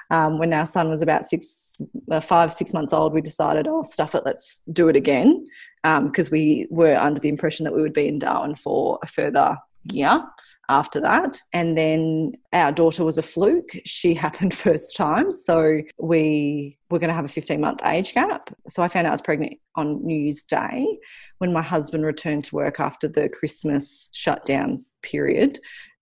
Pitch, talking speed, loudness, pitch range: 160 Hz, 195 wpm, -22 LUFS, 155-175 Hz